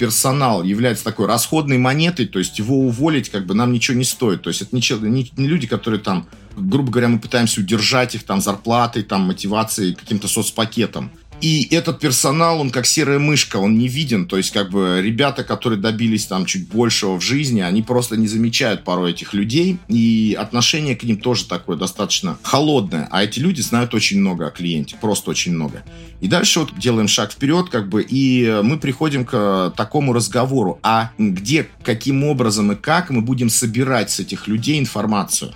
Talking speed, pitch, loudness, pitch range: 185 wpm, 115 Hz, -17 LUFS, 100-135 Hz